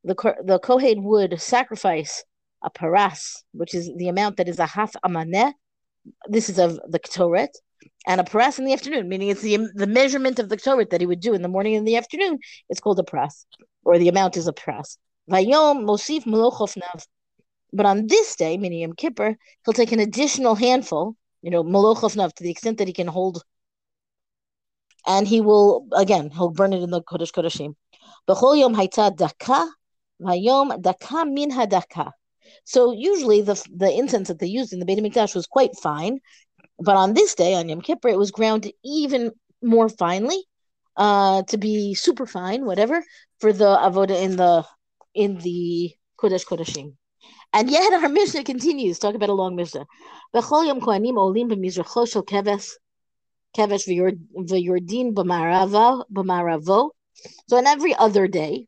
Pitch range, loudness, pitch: 180-245 Hz, -20 LUFS, 205 Hz